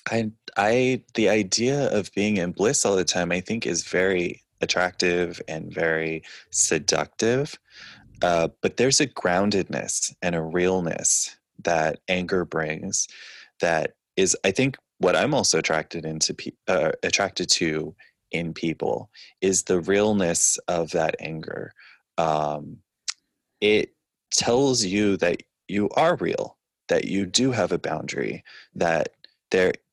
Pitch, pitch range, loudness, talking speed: 90 Hz, 85-105 Hz, -23 LUFS, 135 wpm